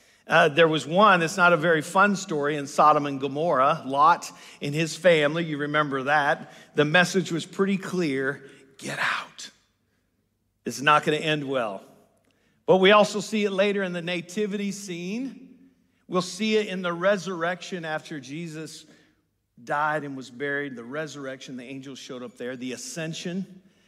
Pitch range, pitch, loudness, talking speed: 145-190 Hz, 160 Hz, -24 LUFS, 165 wpm